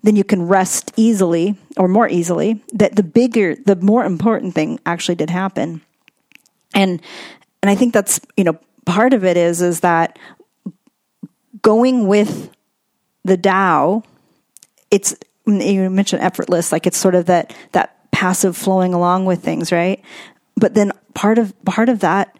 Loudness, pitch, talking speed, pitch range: -16 LUFS, 195 Hz, 155 wpm, 180-220 Hz